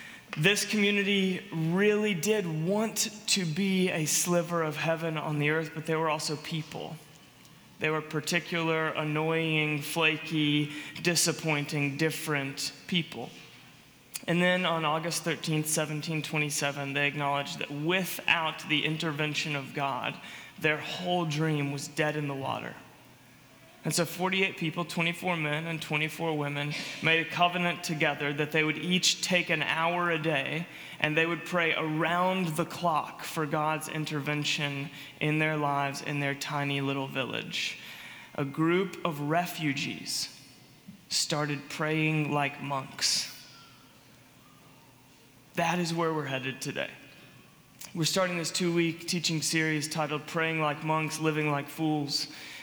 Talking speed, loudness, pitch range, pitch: 135 wpm, -29 LUFS, 145-170 Hz, 155 Hz